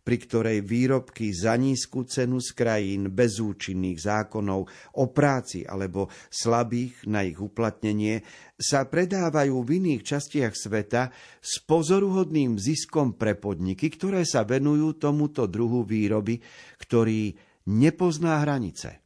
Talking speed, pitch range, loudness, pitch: 120 wpm, 105-145 Hz, -26 LUFS, 120 Hz